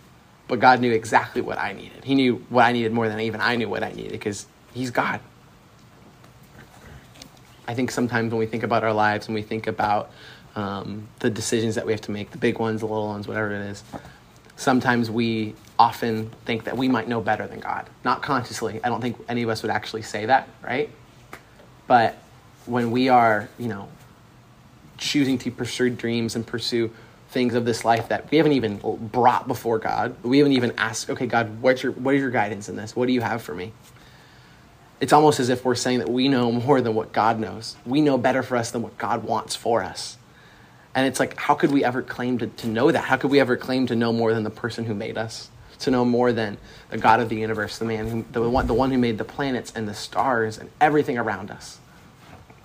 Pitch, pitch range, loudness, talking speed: 115 Hz, 110-125 Hz, -23 LUFS, 225 wpm